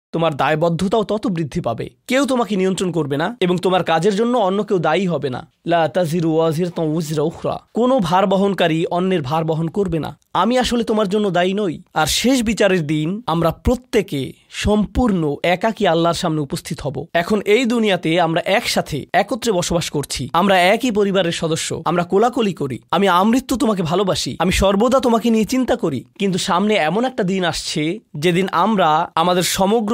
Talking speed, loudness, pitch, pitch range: 160 wpm, -18 LUFS, 185 Hz, 165-215 Hz